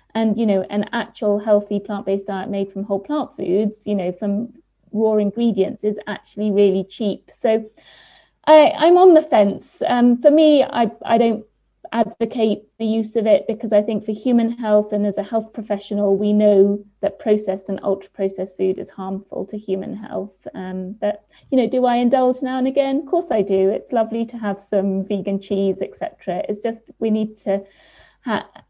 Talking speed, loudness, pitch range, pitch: 190 wpm, -19 LUFS, 200-230 Hz, 210 Hz